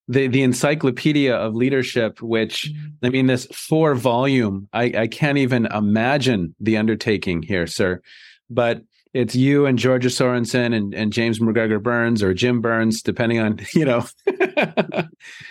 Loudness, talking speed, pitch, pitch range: -20 LUFS, 145 wpm, 120 Hz, 110-130 Hz